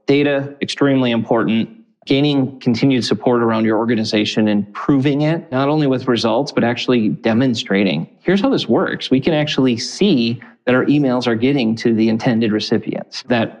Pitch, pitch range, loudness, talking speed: 125 Hz, 115-140 Hz, -17 LUFS, 165 wpm